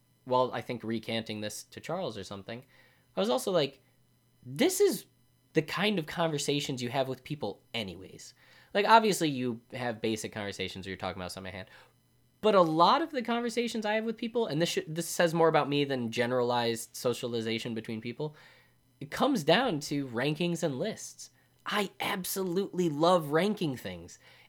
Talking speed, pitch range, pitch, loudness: 175 wpm, 120-170 Hz, 130 Hz, -30 LUFS